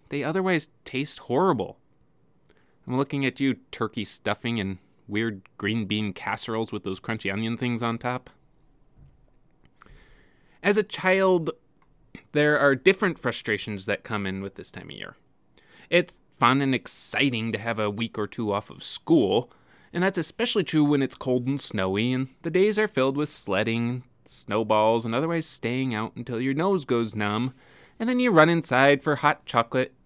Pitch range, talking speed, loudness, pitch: 110-150 Hz, 170 wpm, -25 LUFS, 125 Hz